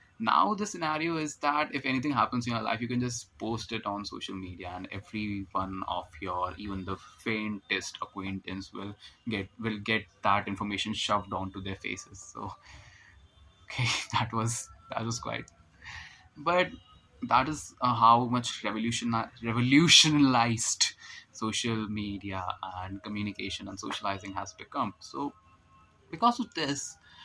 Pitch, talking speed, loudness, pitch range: 110 Hz, 140 wpm, -29 LUFS, 95-125 Hz